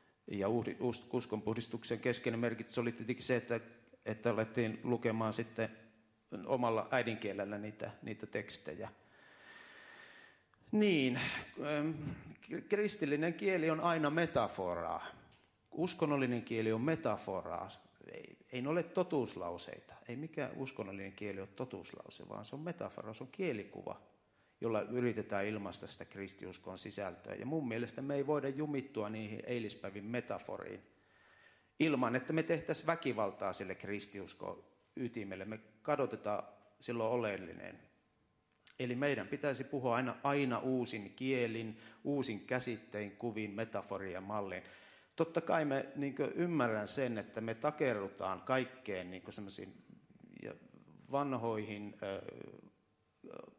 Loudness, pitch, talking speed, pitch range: -39 LUFS, 120 Hz, 110 wpm, 105-140 Hz